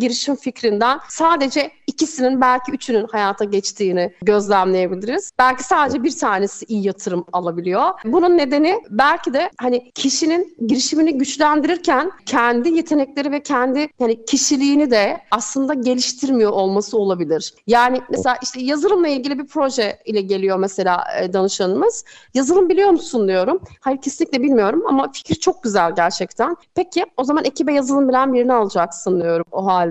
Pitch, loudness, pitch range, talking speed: 255 Hz, -18 LUFS, 205-295 Hz, 140 wpm